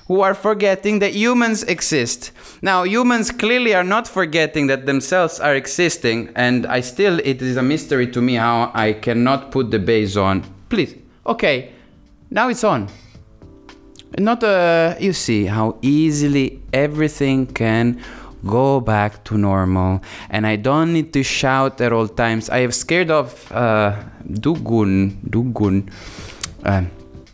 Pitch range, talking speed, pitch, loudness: 110-165 Hz, 145 wpm, 125 Hz, -18 LUFS